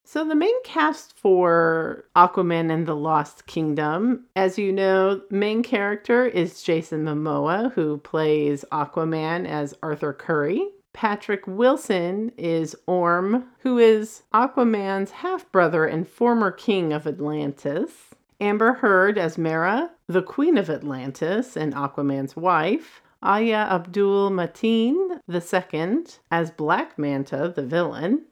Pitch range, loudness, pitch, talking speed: 160-225 Hz, -22 LUFS, 185 Hz, 120 wpm